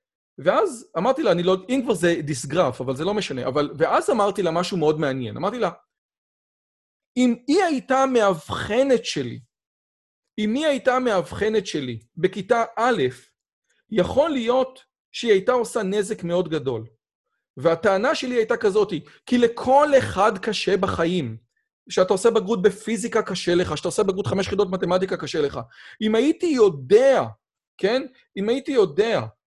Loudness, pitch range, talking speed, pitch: -22 LUFS, 175-255 Hz, 145 wpm, 215 Hz